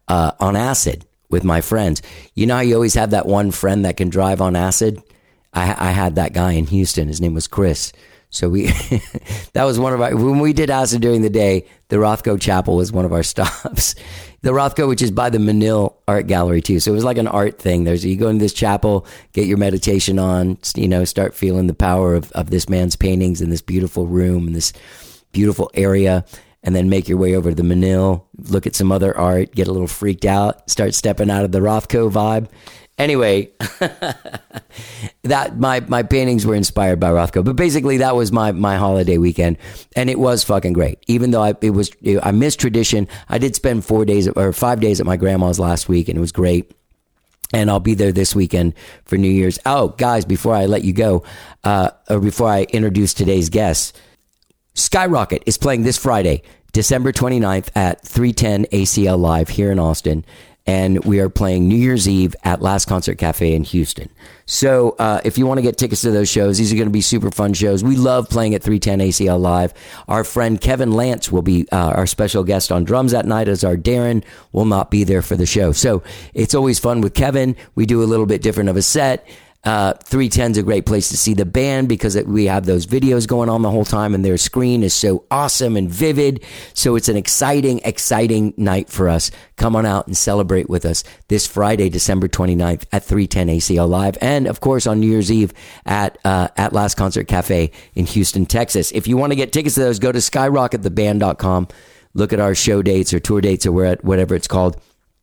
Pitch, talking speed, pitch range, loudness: 100 Hz, 215 wpm, 90-110 Hz, -16 LUFS